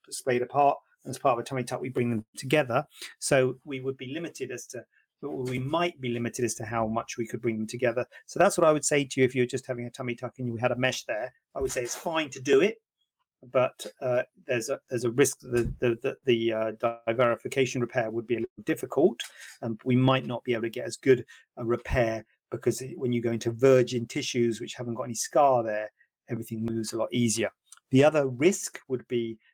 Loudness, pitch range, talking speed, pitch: -28 LUFS, 115-130 Hz, 240 wpm, 125 Hz